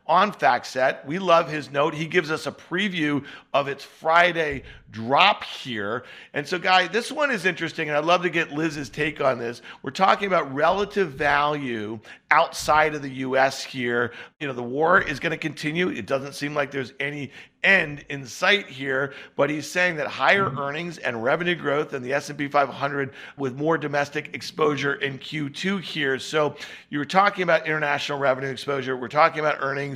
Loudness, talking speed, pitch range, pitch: -23 LUFS, 185 wpm, 140-165 Hz, 145 Hz